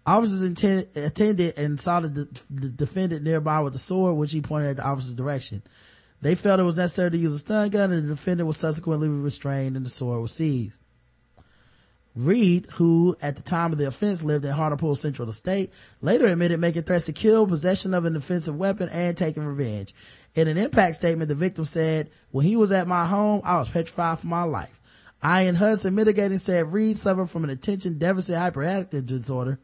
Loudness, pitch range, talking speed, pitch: -24 LUFS, 145-185 Hz, 200 wpm, 165 Hz